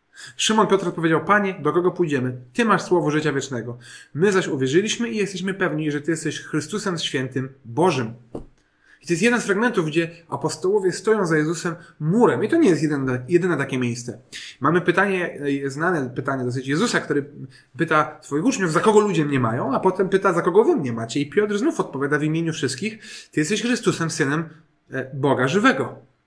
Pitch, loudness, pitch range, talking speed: 165 Hz, -21 LUFS, 140-190 Hz, 185 wpm